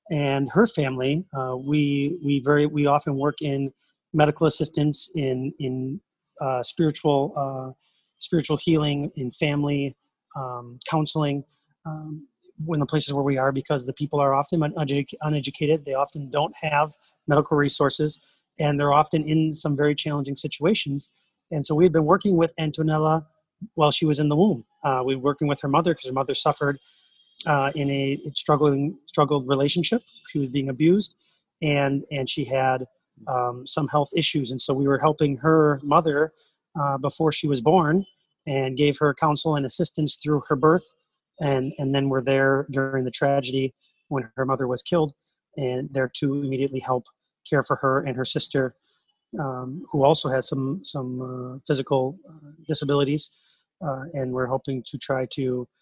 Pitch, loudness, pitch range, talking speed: 145 Hz, -24 LUFS, 135-155 Hz, 165 wpm